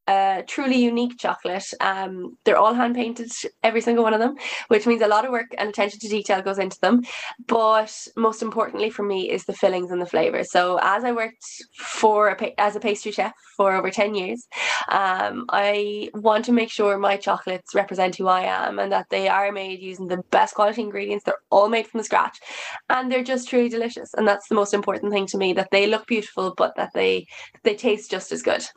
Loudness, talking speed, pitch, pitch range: -22 LUFS, 215 wpm, 210 Hz, 195-230 Hz